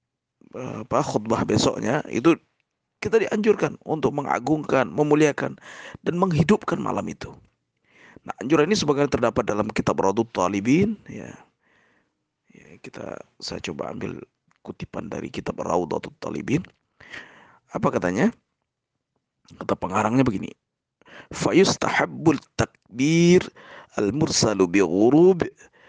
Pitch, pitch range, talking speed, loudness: 150 Hz, 125-205 Hz, 100 wpm, -22 LUFS